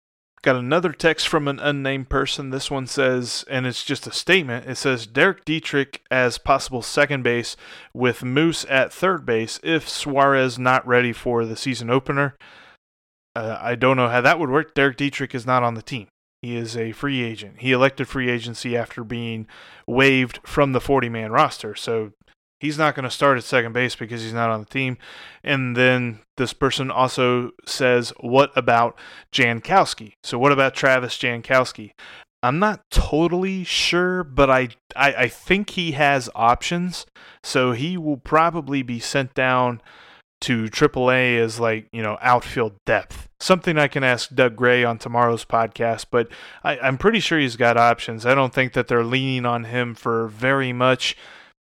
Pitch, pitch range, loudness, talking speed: 130 Hz, 120-140 Hz, -20 LUFS, 175 wpm